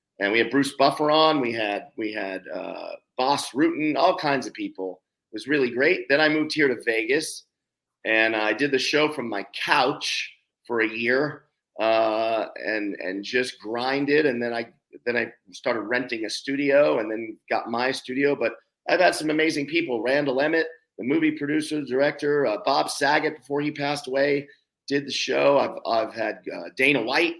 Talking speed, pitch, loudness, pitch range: 185 wpm, 140 Hz, -24 LUFS, 115-150 Hz